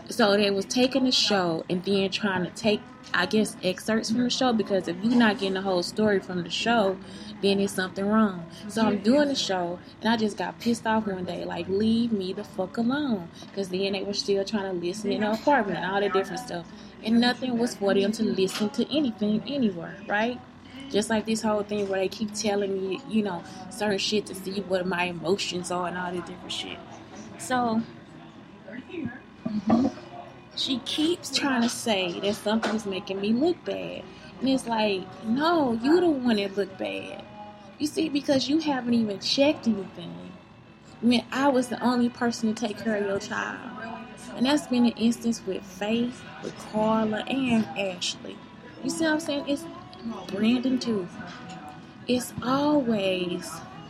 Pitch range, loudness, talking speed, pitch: 195-240 Hz, -26 LUFS, 185 wpm, 215 Hz